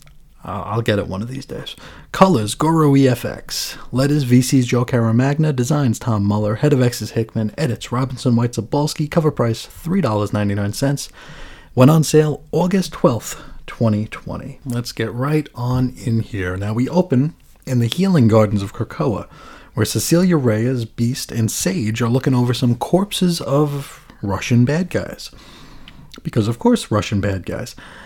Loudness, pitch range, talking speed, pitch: -18 LUFS, 115-150 Hz, 150 wpm, 125 Hz